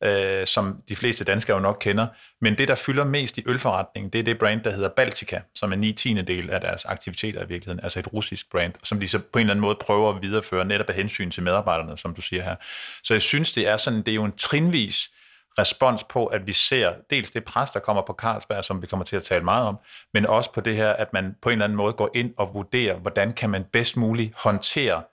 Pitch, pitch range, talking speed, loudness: 105 Hz, 95-115 Hz, 260 wpm, -23 LUFS